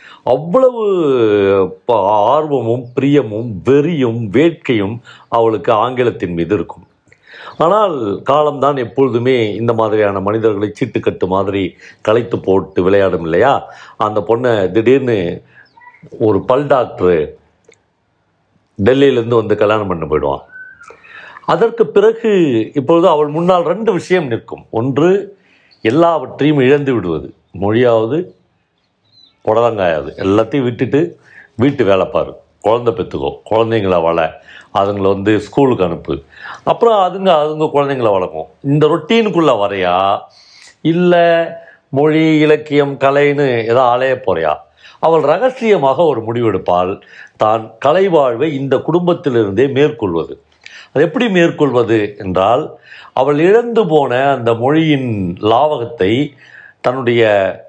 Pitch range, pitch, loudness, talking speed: 110-165 Hz, 135 Hz, -14 LUFS, 100 wpm